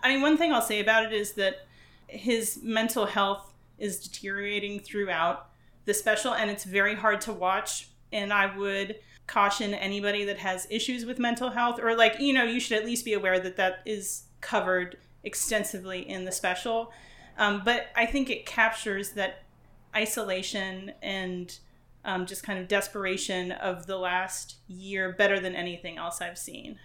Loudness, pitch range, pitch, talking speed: -28 LUFS, 190-225 Hz, 205 Hz, 170 wpm